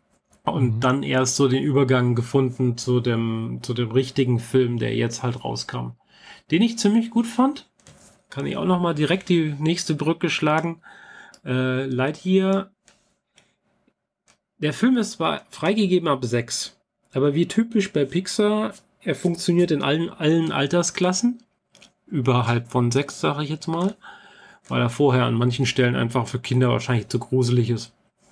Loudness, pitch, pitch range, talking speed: -22 LUFS, 145 Hz, 125-180 Hz, 155 wpm